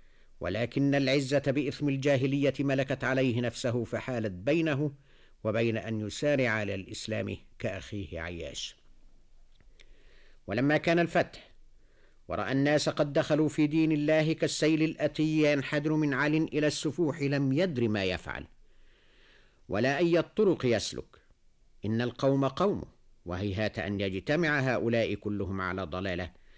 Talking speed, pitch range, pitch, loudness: 115 wpm, 105-150 Hz, 130 Hz, -29 LUFS